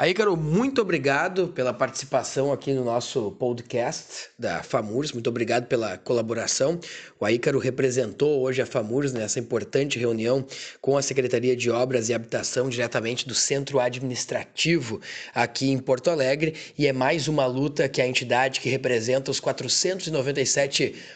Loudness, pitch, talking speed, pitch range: -25 LUFS, 130 Hz, 145 wpm, 125-140 Hz